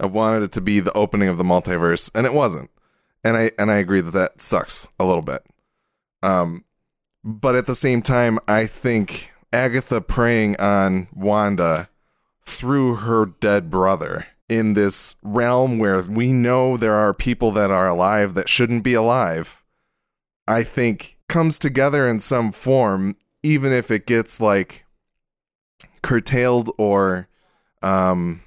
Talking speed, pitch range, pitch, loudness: 150 wpm, 95-120 Hz, 110 Hz, -19 LUFS